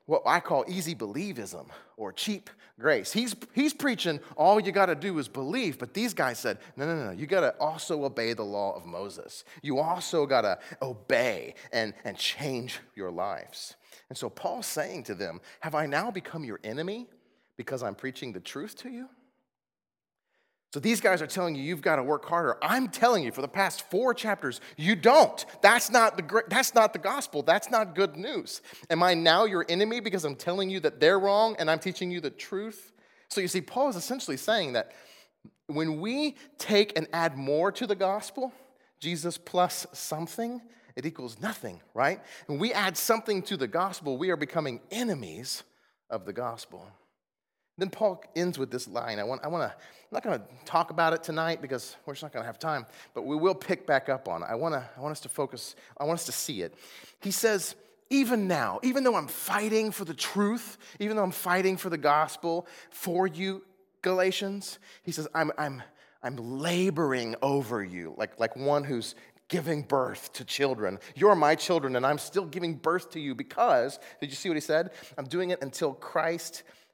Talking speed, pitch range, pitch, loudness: 200 wpm, 150-210 Hz, 180 Hz, -29 LUFS